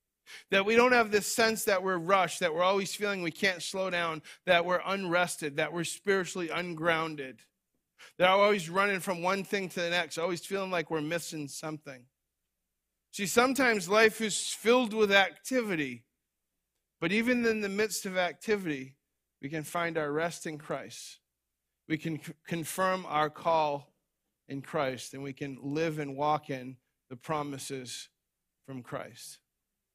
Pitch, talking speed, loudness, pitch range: 170 Hz, 160 wpm, -30 LUFS, 145-195 Hz